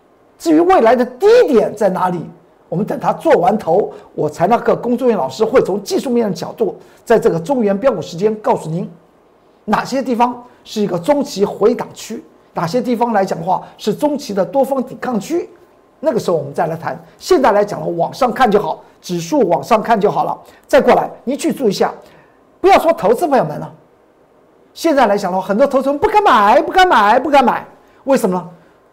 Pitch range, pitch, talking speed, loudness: 200-285 Hz, 240 Hz, 305 characters per minute, -15 LUFS